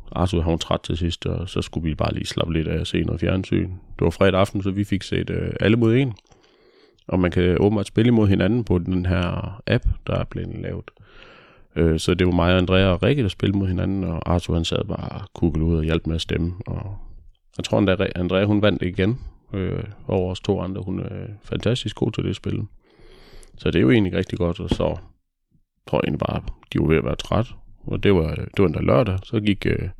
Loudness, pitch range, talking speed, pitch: -22 LUFS, 90-105 Hz, 245 wpm, 95 Hz